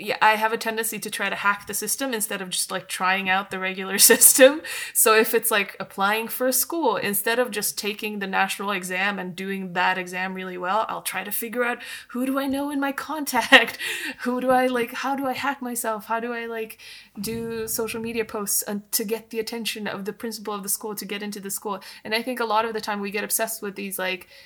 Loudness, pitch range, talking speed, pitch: -23 LUFS, 200-235 Hz, 245 wpm, 220 Hz